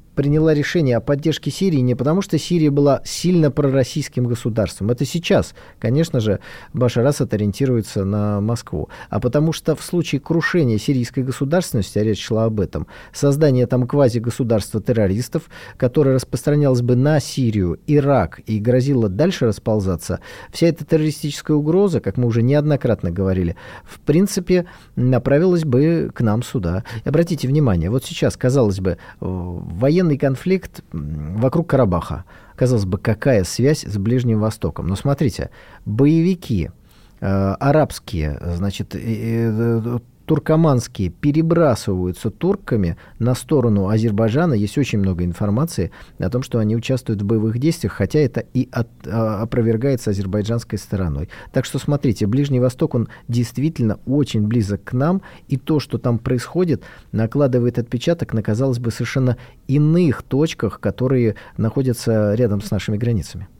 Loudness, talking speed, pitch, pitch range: -19 LUFS, 140 wpm, 125 Hz, 105-145 Hz